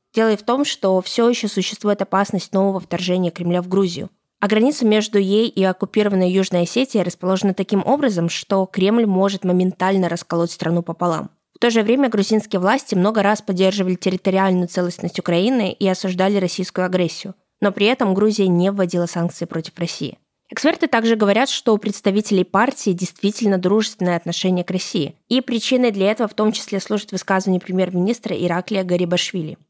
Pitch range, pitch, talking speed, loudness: 180-215 Hz, 195 Hz, 165 wpm, -19 LUFS